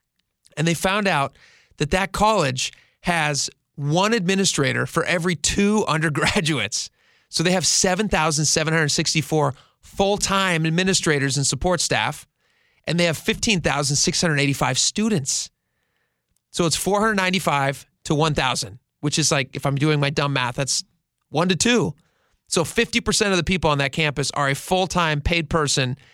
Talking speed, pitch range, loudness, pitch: 140 wpm, 145-185 Hz, -20 LUFS, 160 Hz